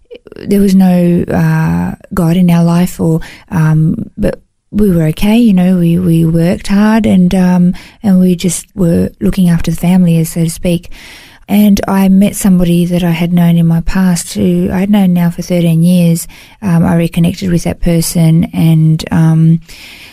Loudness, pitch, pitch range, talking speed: -10 LUFS, 175 Hz, 170-190 Hz, 180 wpm